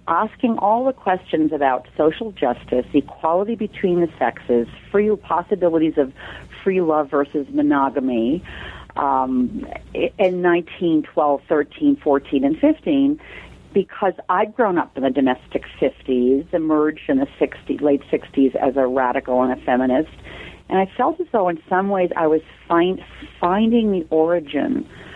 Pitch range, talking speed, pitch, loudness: 140-205 Hz, 140 wpm, 165 Hz, -20 LUFS